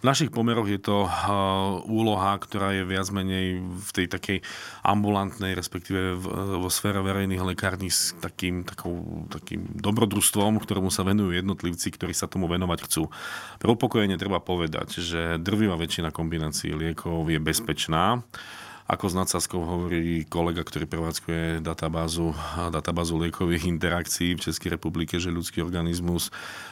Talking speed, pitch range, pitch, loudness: 135 wpm, 85-100 Hz, 90 Hz, -27 LUFS